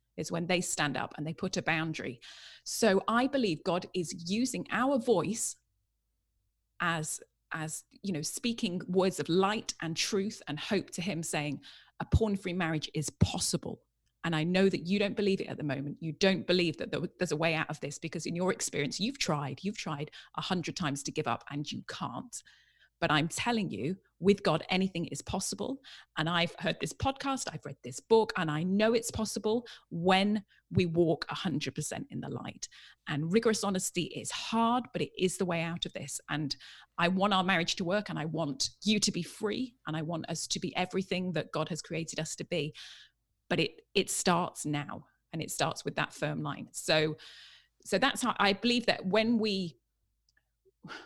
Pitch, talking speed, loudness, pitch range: 175 Hz, 195 wpm, -32 LUFS, 155-200 Hz